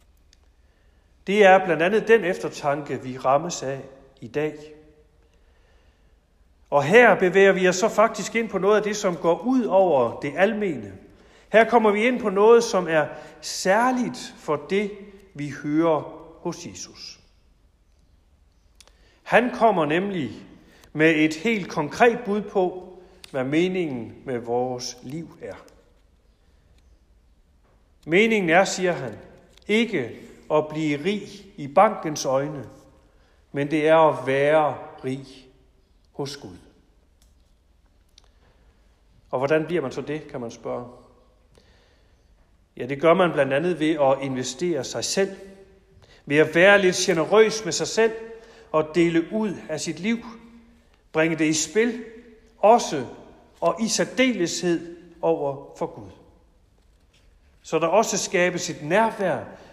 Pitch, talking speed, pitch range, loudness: 155 Hz, 130 wpm, 115-195 Hz, -22 LUFS